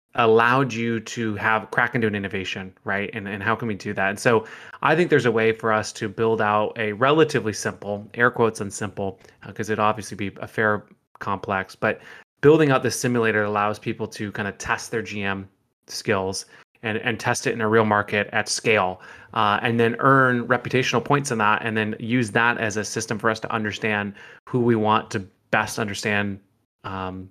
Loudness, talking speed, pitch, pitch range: -22 LUFS, 205 wpm, 110 Hz, 105-115 Hz